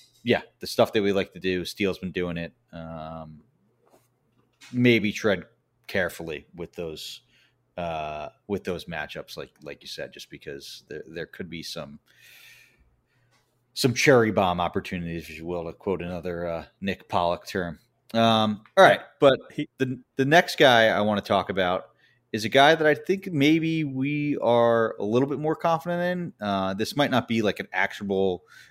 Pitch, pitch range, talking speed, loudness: 110 Hz, 90-140 Hz, 175 wpm, -24 LUFS